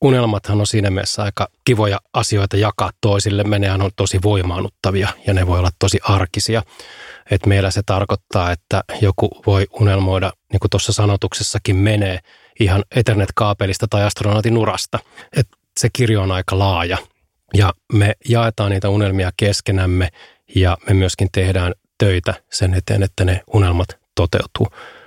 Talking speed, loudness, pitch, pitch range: 145 wpm, -17 LUFS, 100 Hz, 95-105 Hz